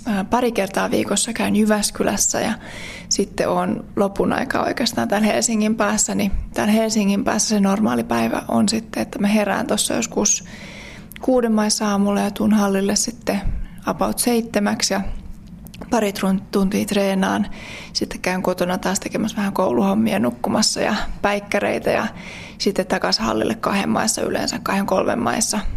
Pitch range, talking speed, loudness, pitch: 195-220 Hz, 140 wpm, -20 LUFS, 205 Hz